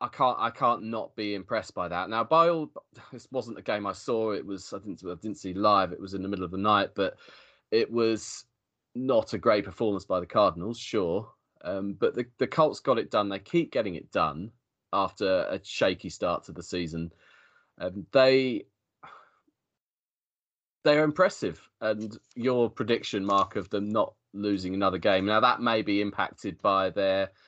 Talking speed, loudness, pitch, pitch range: 190 wpm, -28 LUFS, 105 Hz, 95-120 Hz